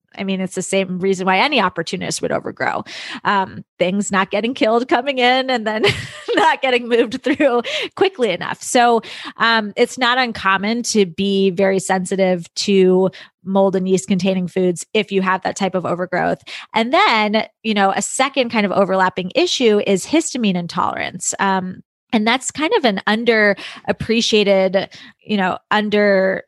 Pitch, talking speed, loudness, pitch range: 200 Hz, 160 wpm, -17 LUFS, 190-235 Hz